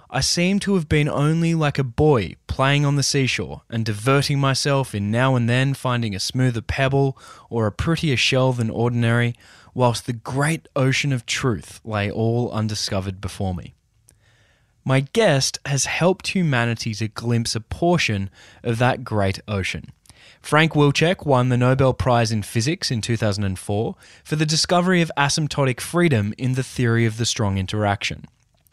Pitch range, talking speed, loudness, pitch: 110-140 Hz, 160 wpm, -21 LUFS, 125 Hz